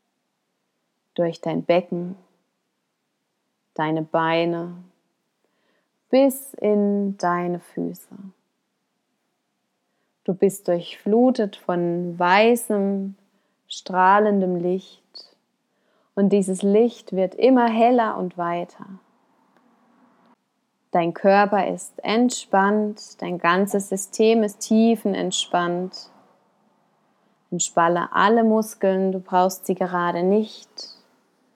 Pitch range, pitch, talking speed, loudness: 180-225 Hz, 200 Hz, 80 wpm, -21 LUFS